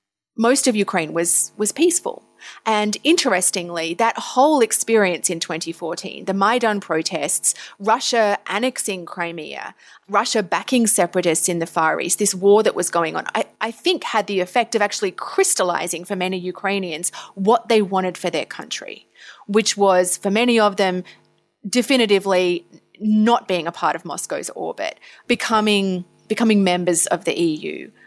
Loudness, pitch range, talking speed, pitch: -19 LUFS, 180-230 Hz, 155 wpm, 200 Hz